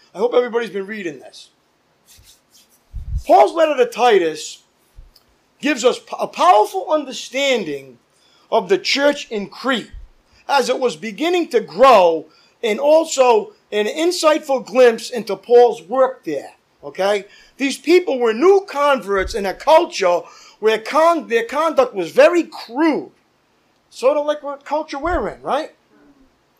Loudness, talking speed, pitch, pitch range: -17 LUFS, 135 wpm, 270 Hz, 220-320 Hz